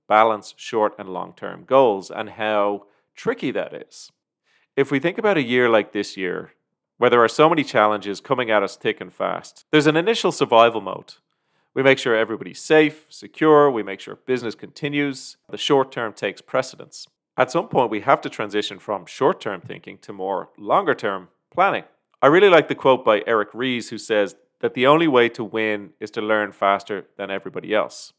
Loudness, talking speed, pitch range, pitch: -20 LUFS, 195 wpm, 105-145 Hz, 115 Hz